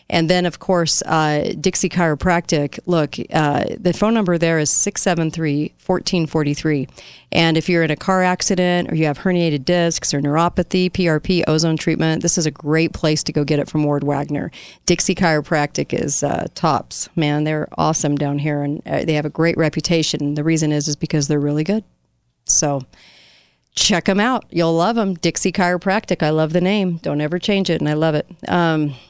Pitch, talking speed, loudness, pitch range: 160 Hz, 185 wpm, -18 LUFS, 150-180 Hz